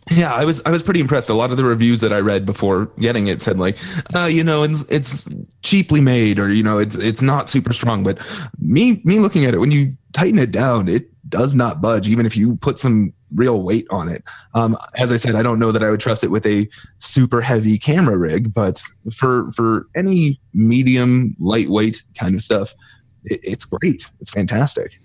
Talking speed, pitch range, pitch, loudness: 215 wpm, 110-145 Hz, 120 Hz, -17 LUFS